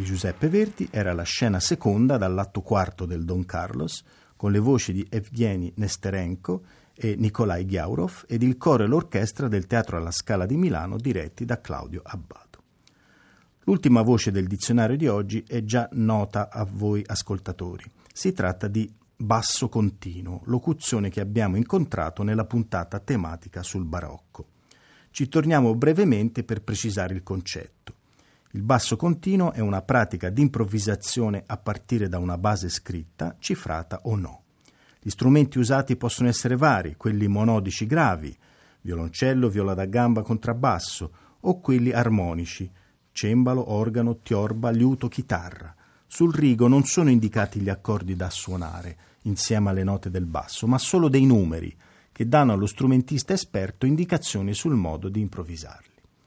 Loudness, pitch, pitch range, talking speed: -24 LUFS, 105 Hz, 95-120 Hz, 145 wpm